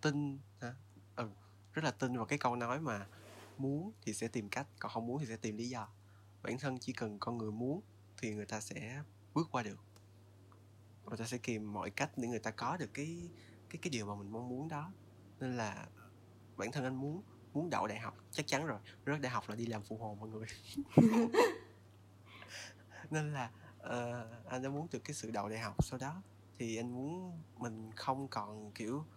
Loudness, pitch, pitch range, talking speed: -40 LUFS, 115 Hz, 105-130 Hz, 210 wpm